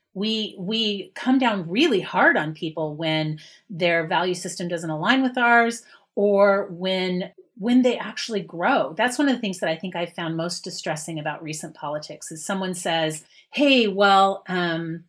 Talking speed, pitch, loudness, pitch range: 170 wpm, 185 Hz, -22 LUFS, 165-220 Hz